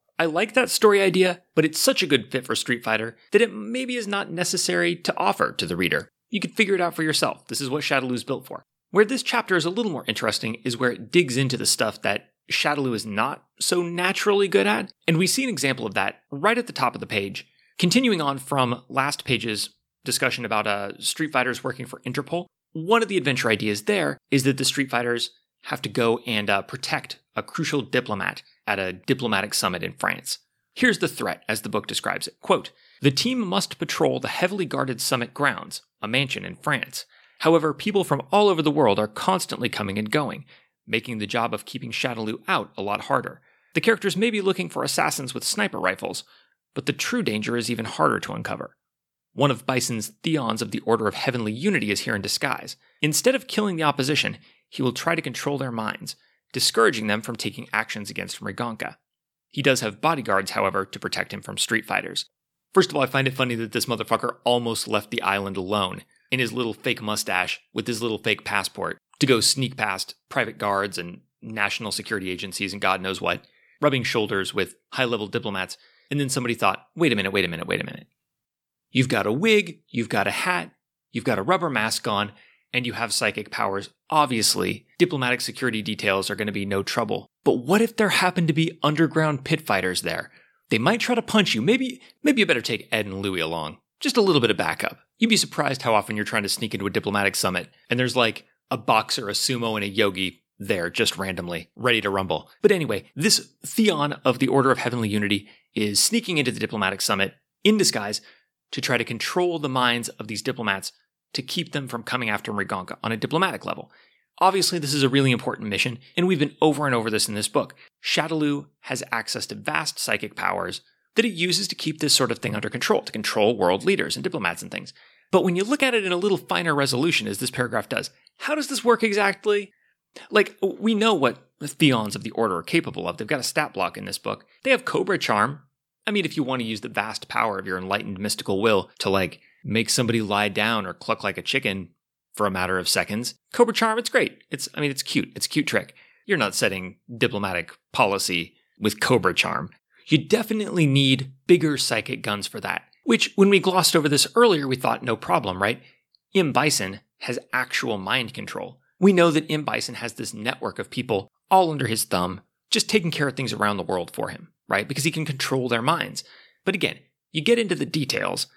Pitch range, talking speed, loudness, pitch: 110-170 Hz, 215 wpm, -23 LUFS, 130 Hz